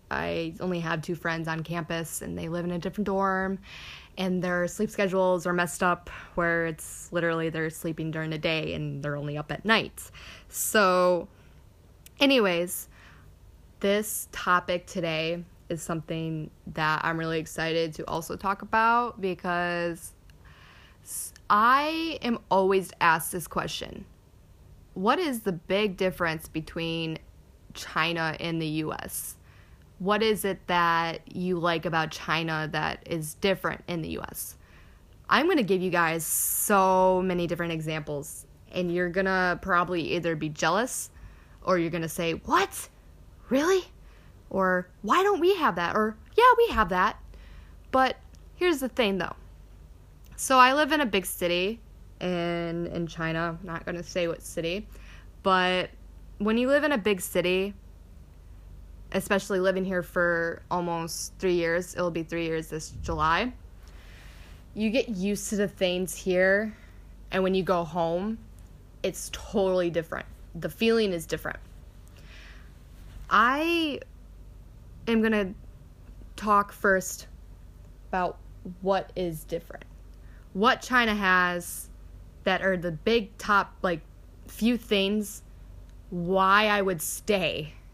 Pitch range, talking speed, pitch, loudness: 160-195 Hz, 135 wpm, 175 Hz, -27 LUFS